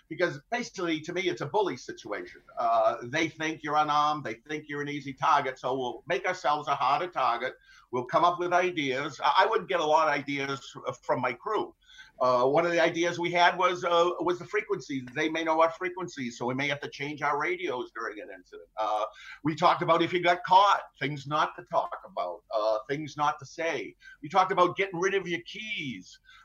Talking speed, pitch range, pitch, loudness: 220 wpm, 145-180 Hz, 165 Hz, -28 LUFS